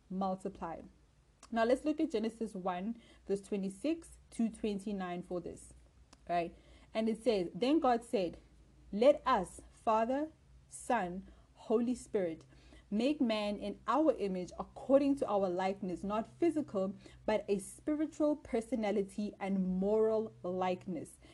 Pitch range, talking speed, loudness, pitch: 190-245 Hz, 125 wpm, -35 LUFS, 210 Hz